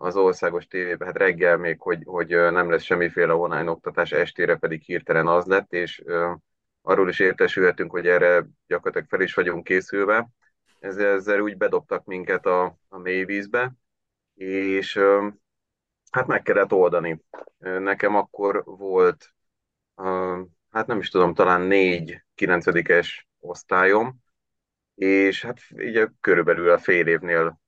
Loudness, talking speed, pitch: -22 LUFS, 130 wpm, 125 Hz